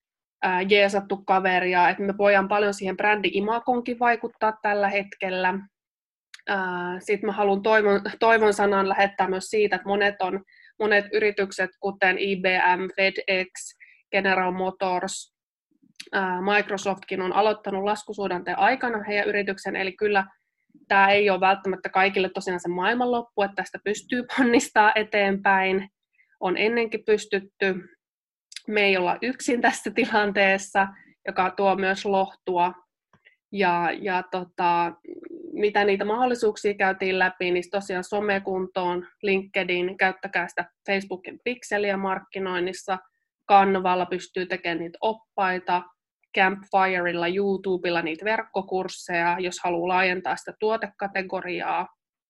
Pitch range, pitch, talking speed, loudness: 185-210 Hz, 195 Hz, 110 wpm, -24 LUFS